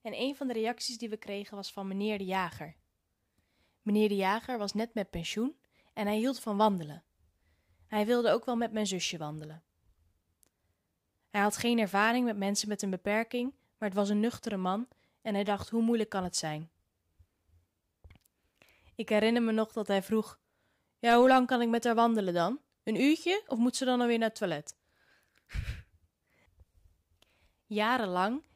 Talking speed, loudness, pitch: 175 wpm, -31 LUFS, 205 Hz